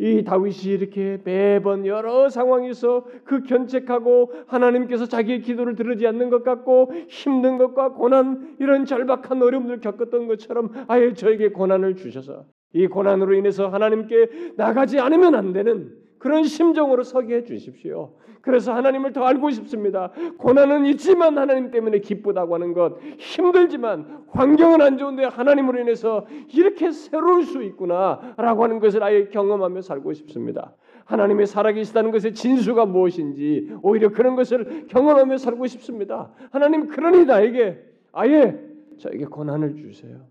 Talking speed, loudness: 360 characters per minute, -19 LUFS